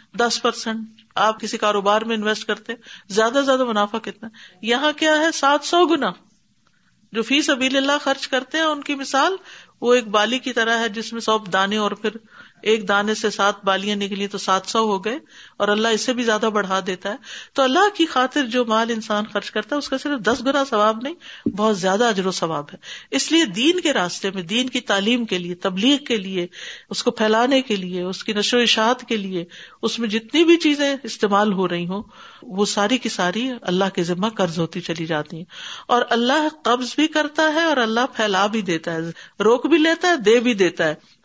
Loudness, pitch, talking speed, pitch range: -20 LUFS, 225 Hz, 220 wpm, 200-265 Hz